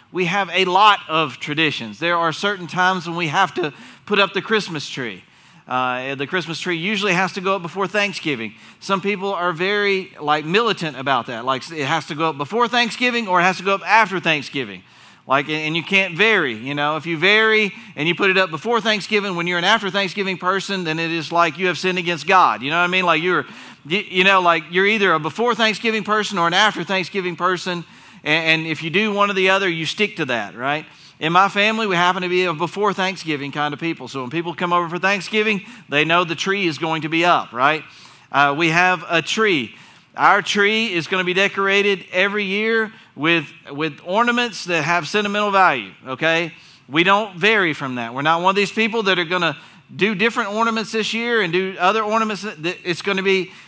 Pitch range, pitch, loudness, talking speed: 165-200 Hz, 185 Hz, -18 LUFS, 225 wpm